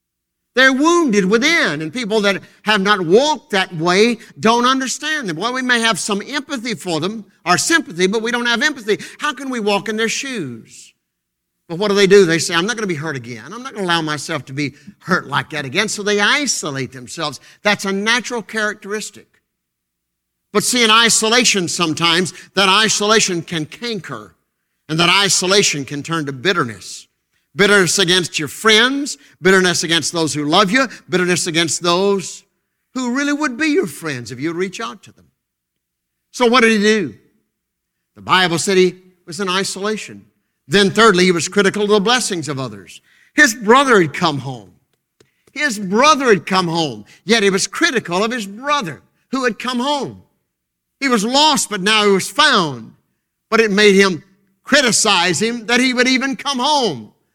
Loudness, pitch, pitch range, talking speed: -15 LUFS, 200 Hz, 165-230 Hz, 185 wpm